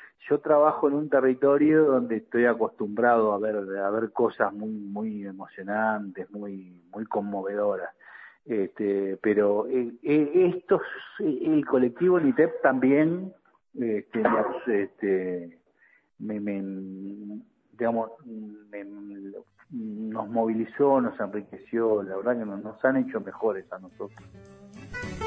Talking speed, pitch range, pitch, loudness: 110 wpm, 100-130 Hz, 110 Hz, -26 LUFS